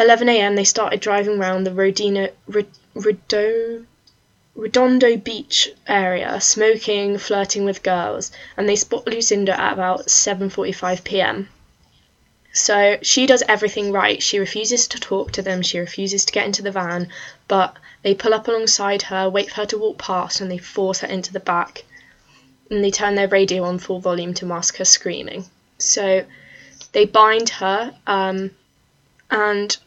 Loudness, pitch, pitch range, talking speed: -18 LUFS, 200 Hz, 190-215 Hz, 155 wpm